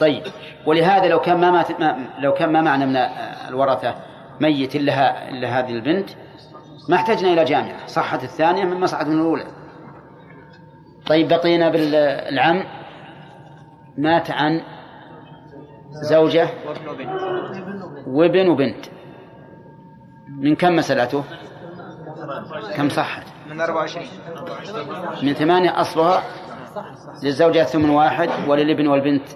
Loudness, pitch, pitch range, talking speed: -19 LUFS, 155 Hz, 150-170 Hz, 100 wpm